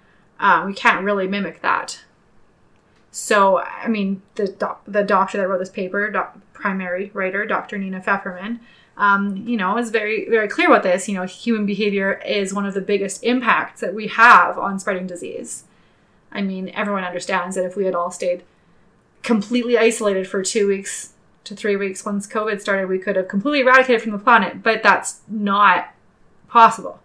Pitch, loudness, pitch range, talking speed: 200 Hz, -19 LUFS, 190-220 Hz, 180 wpm